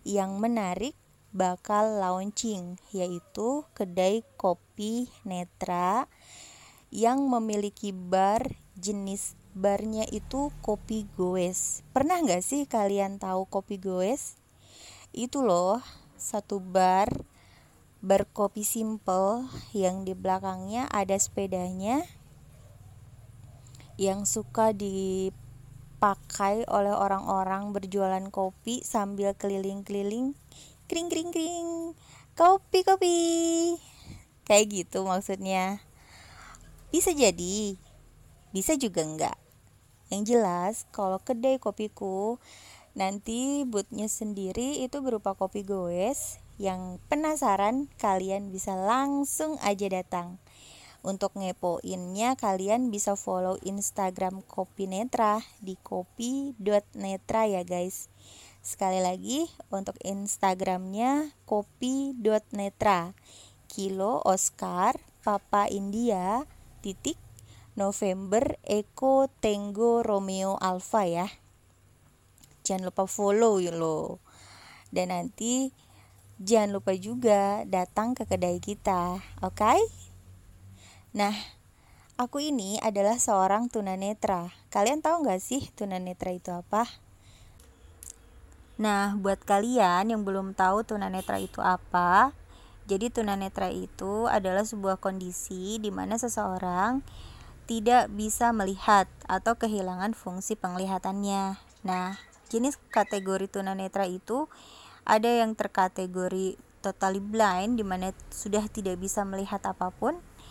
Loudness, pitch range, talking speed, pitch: -29 LUFS, 185-220 Hz, 95 wpm, 200 Hz